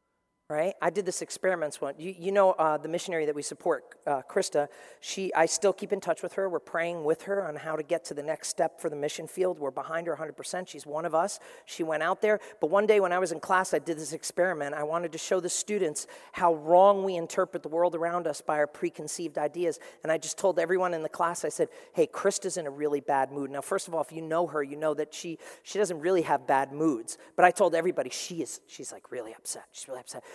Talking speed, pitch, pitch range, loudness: 260 wpm, 170 Hz, 155-185 Hz, -29 LUFS